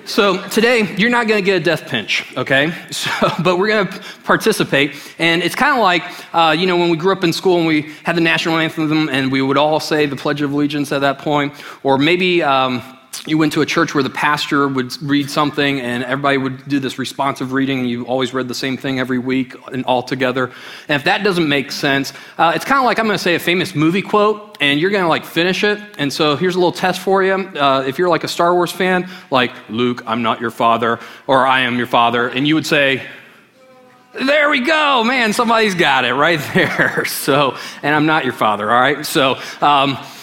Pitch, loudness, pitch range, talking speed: 155 Hz, -16 LUFS, 135-185 Hz, 235 wpm